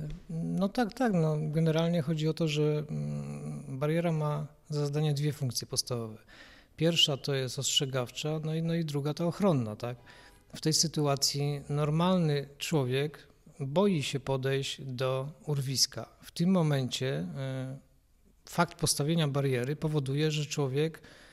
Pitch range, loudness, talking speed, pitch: 135-160 Hz, -30 LUFS, 130 wpm, 150 Hz